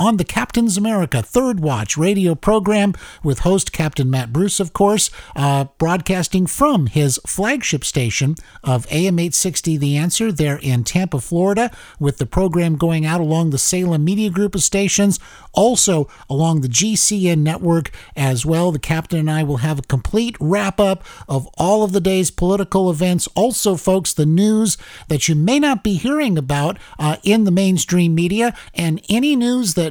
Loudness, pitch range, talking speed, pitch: -17 LUFS, 155-200 Hz, 175 wpm, 175 Hz